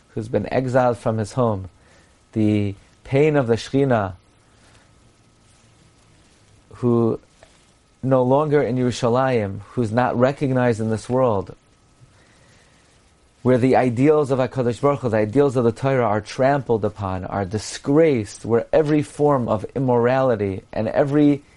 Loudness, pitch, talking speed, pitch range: -20 LUFS, 120 Hz, 120 wpm, 105-130 Hz